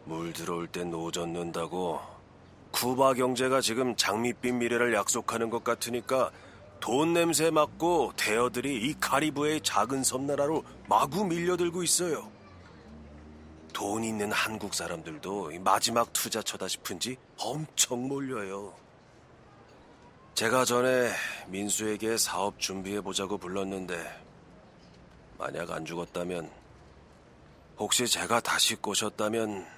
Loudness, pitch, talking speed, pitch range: -29 LUFS, 115 Hz, 245 characters per minute, 90-130 Hz